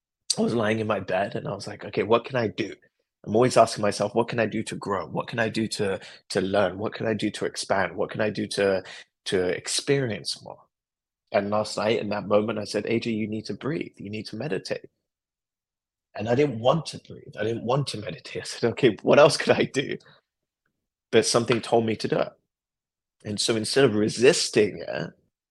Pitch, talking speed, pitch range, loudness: 110 Hz, 225 wpm, 105-115 Hz, -25 LUFS